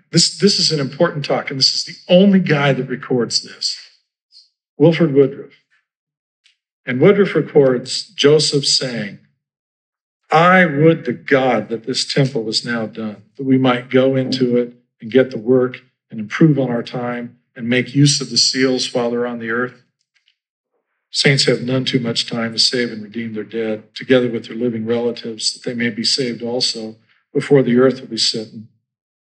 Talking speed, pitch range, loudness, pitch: 180 wpm, 115-140 Hz, -16 LUFS, 125 Hz